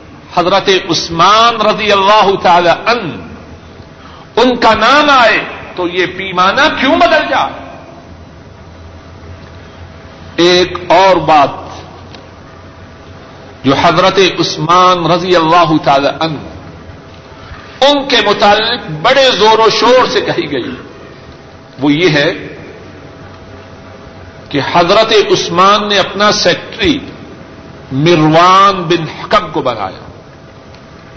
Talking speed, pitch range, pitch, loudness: 95 wpm, 135-215 Hz, 175 Hz, -9 LUFS